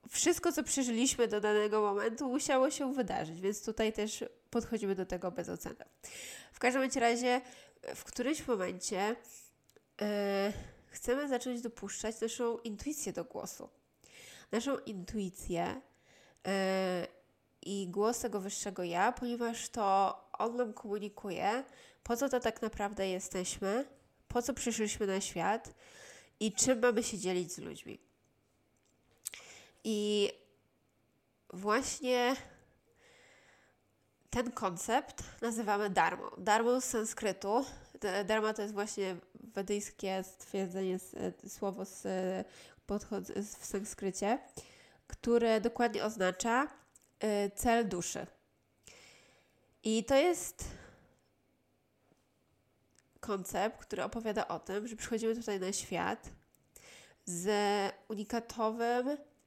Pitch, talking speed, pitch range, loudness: 215 Hz, 100 wpm, 200-245 Hz, -35 LUFS